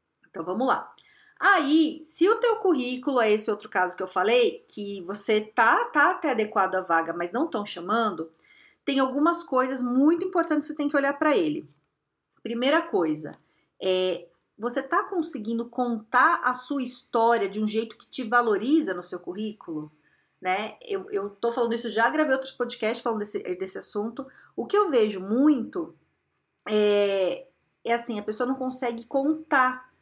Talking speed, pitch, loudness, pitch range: 170 wpm, 250 Hz, -25 LUFS, 215-310 Hz